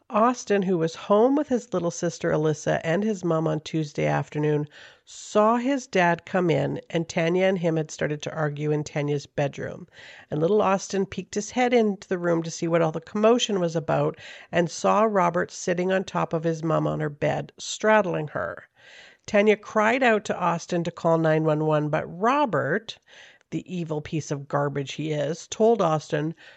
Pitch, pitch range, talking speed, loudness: 170 Hz, 155-205 Hz, 185 wpm, -24 LUFS